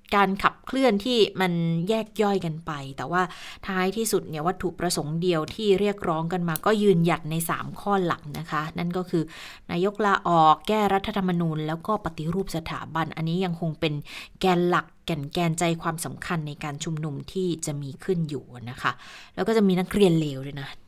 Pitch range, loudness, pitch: 155-195 Hz, -25 LUFS, 175 Hz